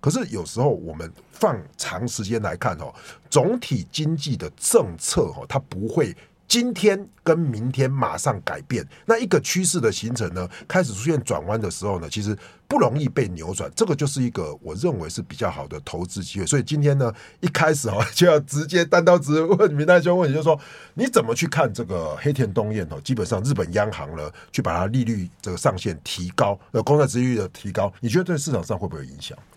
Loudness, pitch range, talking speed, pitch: -22 LUFS, 105-160 Hz, 320 characters per minute, 130 Hz